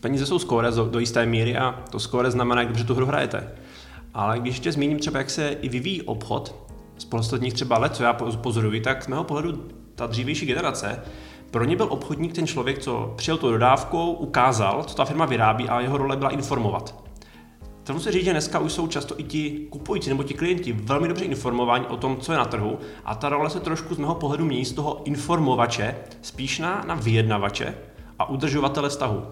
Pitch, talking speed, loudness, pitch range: 130 Hz, 205 wpm, -24 LUFS, 115-150 Hz